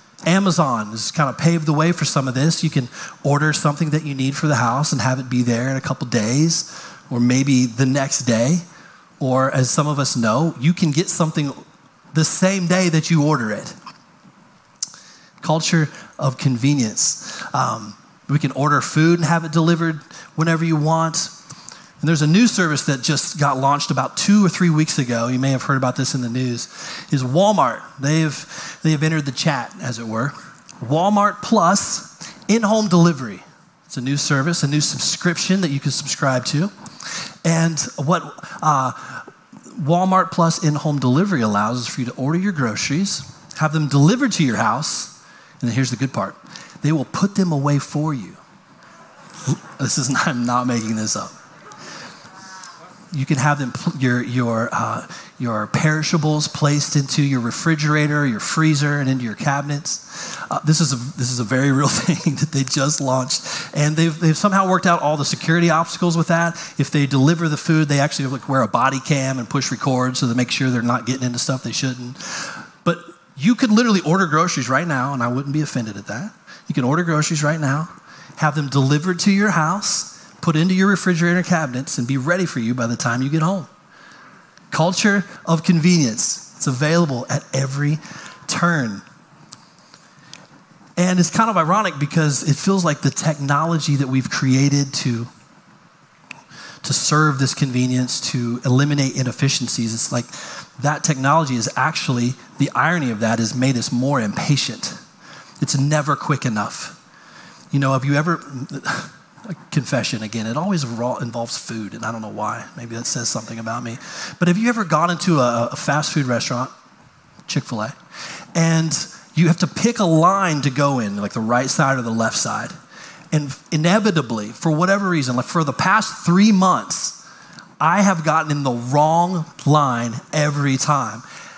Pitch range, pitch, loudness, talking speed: 130-170 Hz, 150 Hz, -19 LUFS, 180 wpm